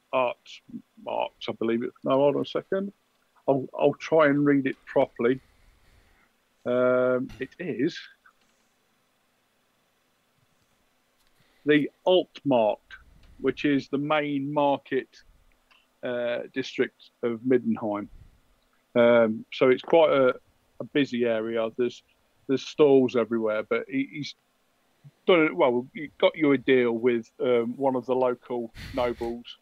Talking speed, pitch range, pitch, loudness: 125 wpm, 120-145 Hz, 130 Hz, -25 LUFS